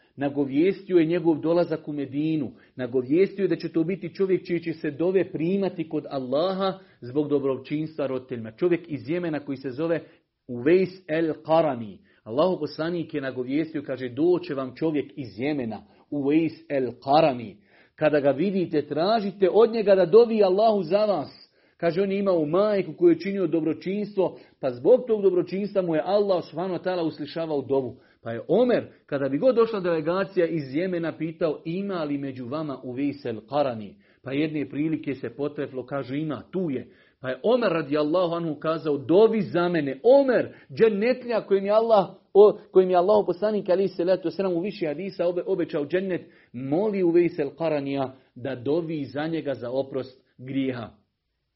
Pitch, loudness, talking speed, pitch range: 160 Hz, -25 LUFS, 165 wpm, 140-185 Hz